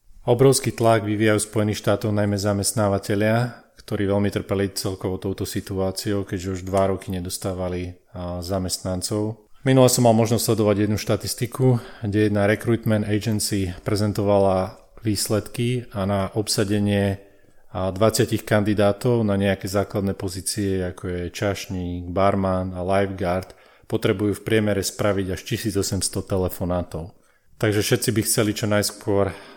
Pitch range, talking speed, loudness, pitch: 95-110 Hz, 120 wpm, -22 LUFS, 100 Hz